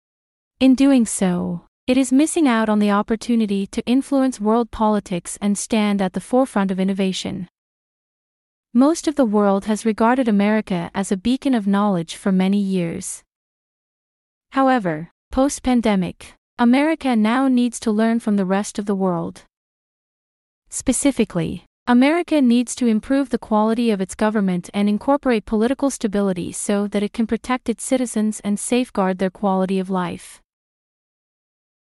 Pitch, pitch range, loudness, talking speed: 220 Hz, 200-250 Hz, -19 LUFS, 145 wpm